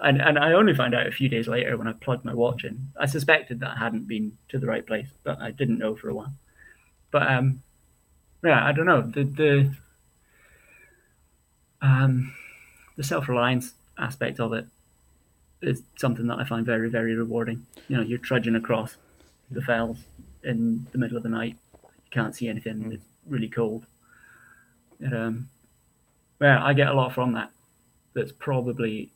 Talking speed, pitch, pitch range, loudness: 180 wpm, 120 Hz, 110-130 Hz, -25 LUFS